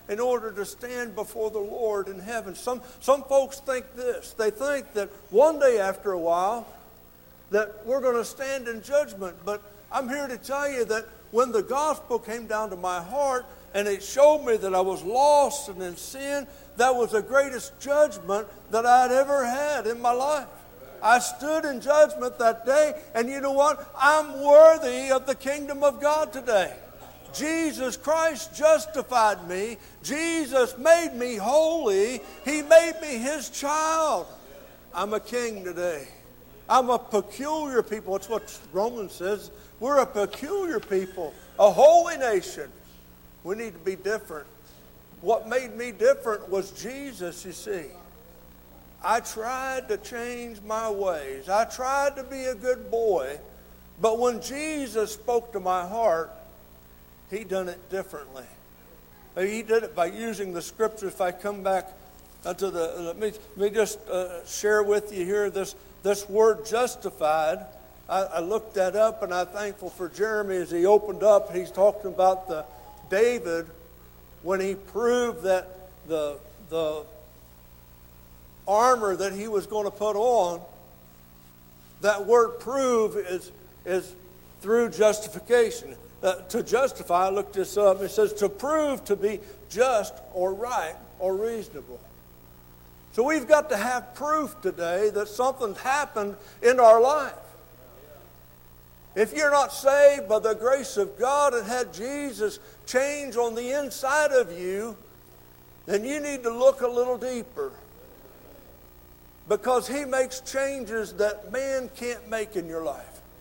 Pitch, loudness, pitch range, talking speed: 220 Hz, -25 LUFS, 185-265 Hz, 150 wpm